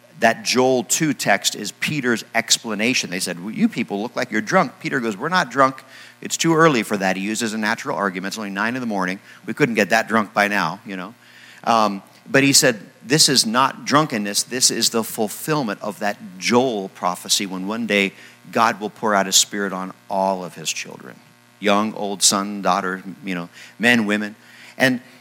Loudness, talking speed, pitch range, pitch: -19 LUFS, 200 wpm, 100-125 Hz, 105 Hz